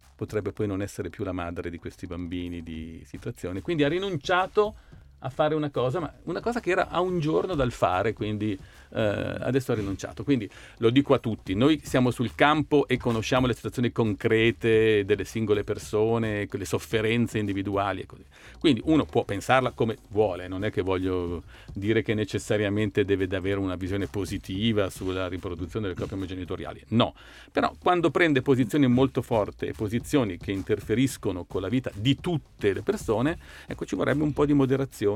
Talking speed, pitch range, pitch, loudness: 175 wpm, 100-135 Hz, 110 Hz, -26 LUFS